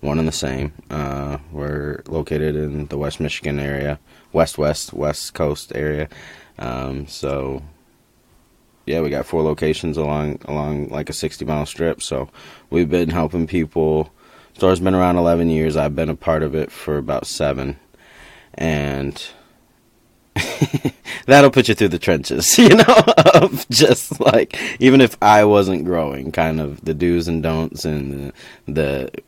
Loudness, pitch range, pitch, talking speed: -17 LUFS, 75-80 Hz, 75 Hz, 155 wpm